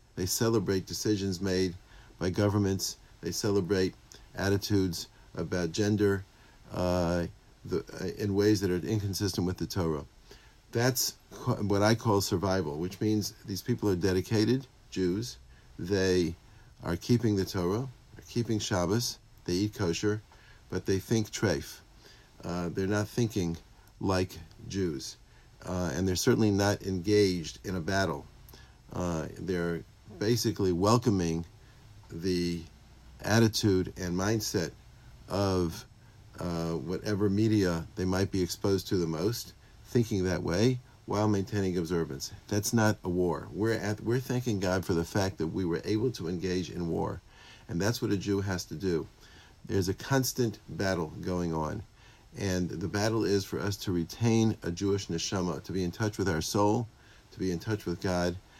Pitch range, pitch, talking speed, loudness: 90-110 Hz, 100 Hz, 150 wpm, -30 LUFS